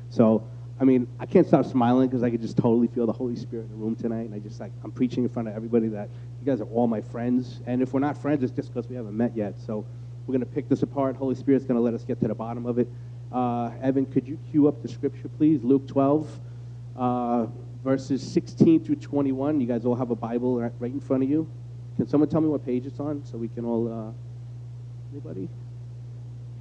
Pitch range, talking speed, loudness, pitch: 120-135 Hz, 245 wpm, -26 LUFS, 120 Hz